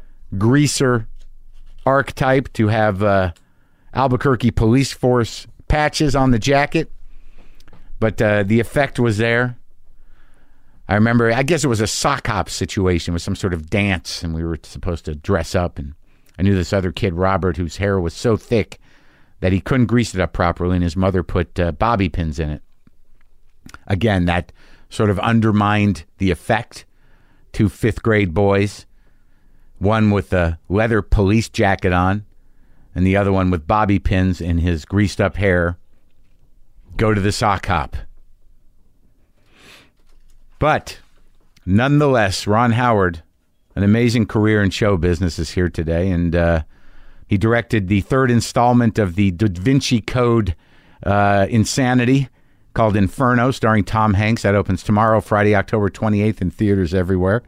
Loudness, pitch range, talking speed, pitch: -18 LUFS, 90-115 Hz, 150 wpm, 100 Hz